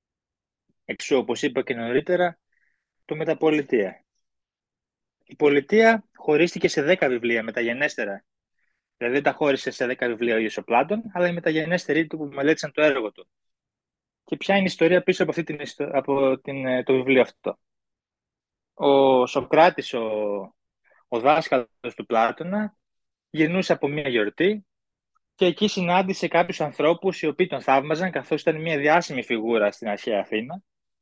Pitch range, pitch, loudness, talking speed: 130-175 Hz, 150 Hz, -23 LUFS, 145 wpm